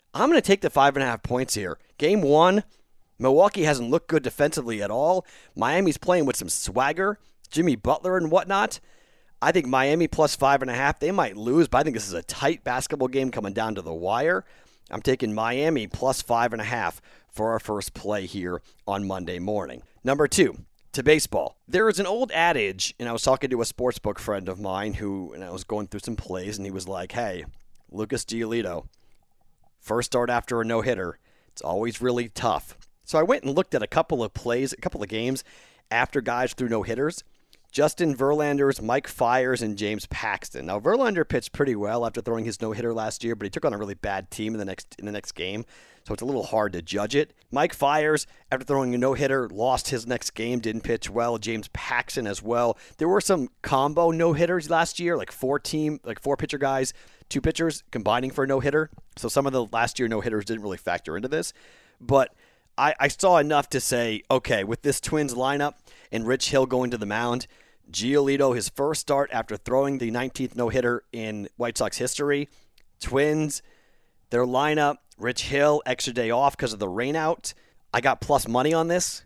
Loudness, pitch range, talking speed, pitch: -25 LUFS, 110-140 Hz, 210 wpm, 125 Hz